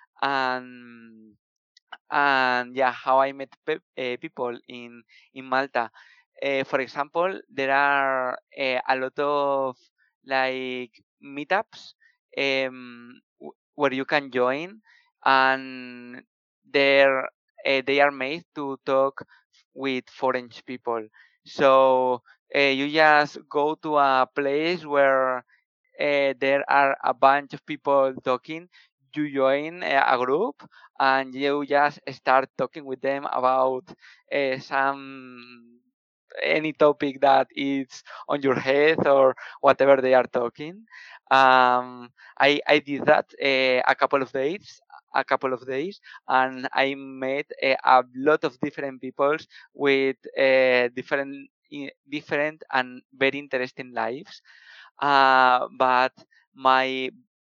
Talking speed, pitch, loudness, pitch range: 125 wpm, 135 Hz, -23 LUFS, 130-145 Hz